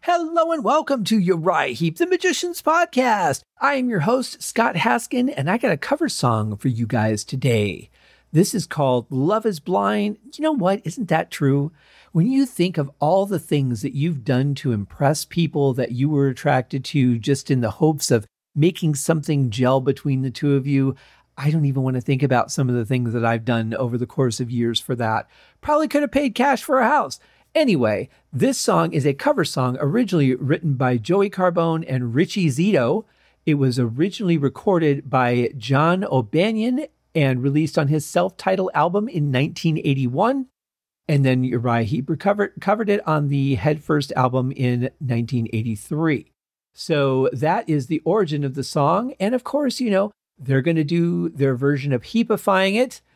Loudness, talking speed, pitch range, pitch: -21 LUFS, 185 wpm, 130-195 Hz, 150 Hz